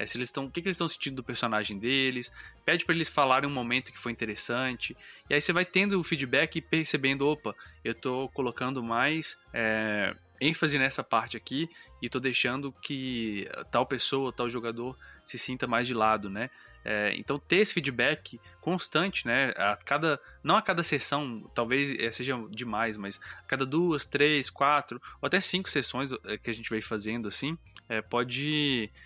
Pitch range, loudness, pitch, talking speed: 115-145 Hz, -29 LUFS, 130 Hz, 185 wpm